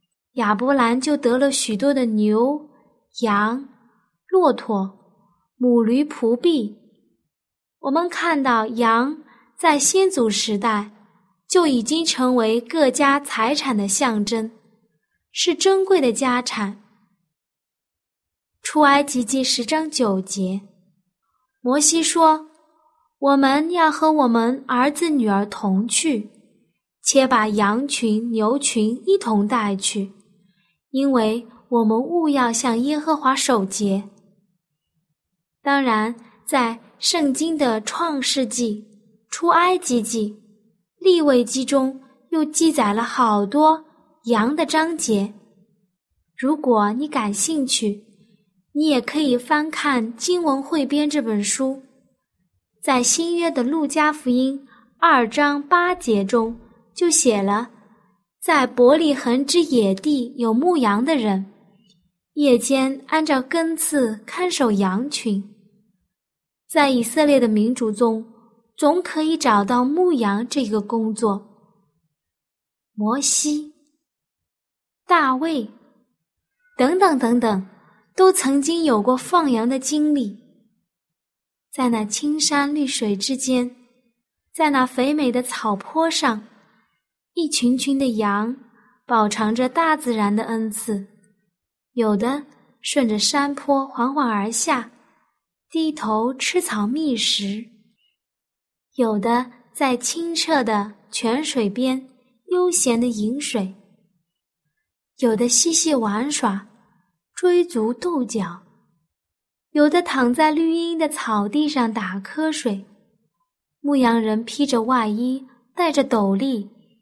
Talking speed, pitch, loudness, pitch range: 155 characters per minute, 245 Hz, -20 LUFS, 215-290 Hz